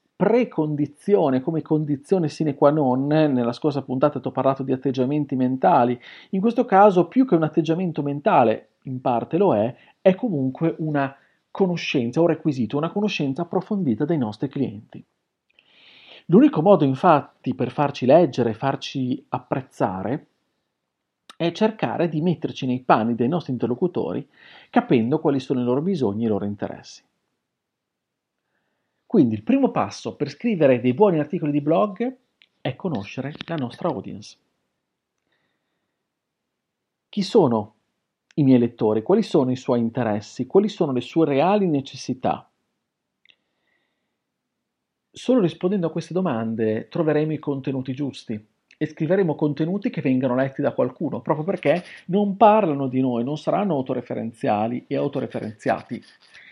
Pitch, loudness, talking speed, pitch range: 145 Hz, -22 LUFS, 135 wpm, 130-175 Hz